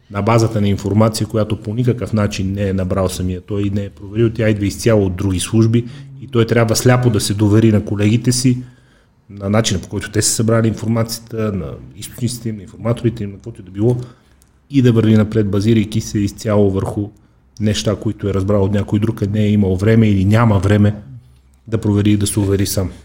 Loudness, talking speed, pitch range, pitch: -16 LUFS, 210 wpm, 100-115 Hz, 105 Hz